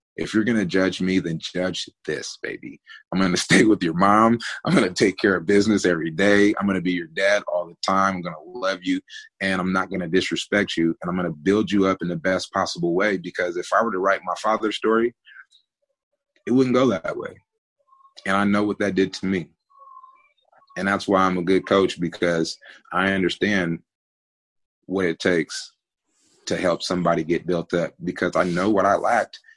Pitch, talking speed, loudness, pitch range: 100 Hz, 215 wpm, -22 LUFS, 90-130 Hz